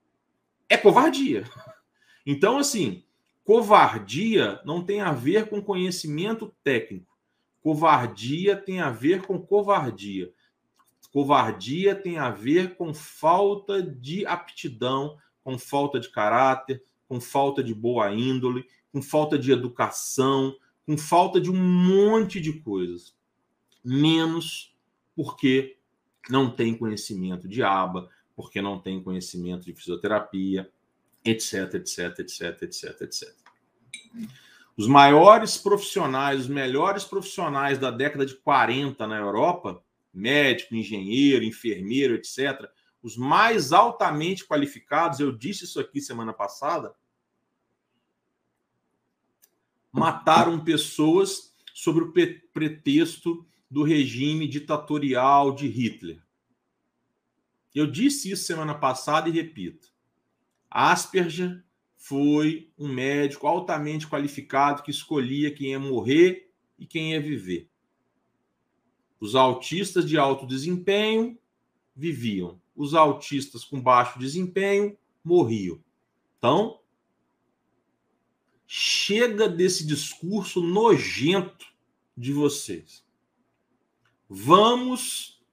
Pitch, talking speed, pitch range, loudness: 145 Hz, 100 wpm, 130-180 Hz, -24 LUFS